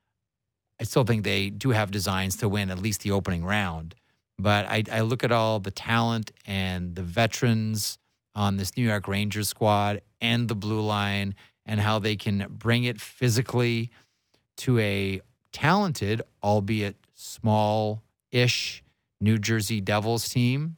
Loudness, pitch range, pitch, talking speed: -26 LUFS, 100-115 Hz, 110 Hz, 150 wpm